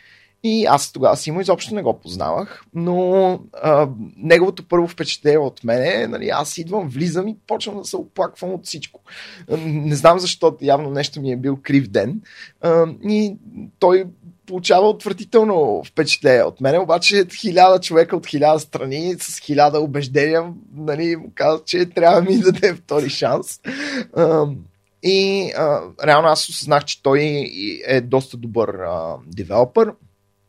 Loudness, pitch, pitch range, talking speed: -18 LUFS, 170 Hz, 145-195 Hz, 150 wpm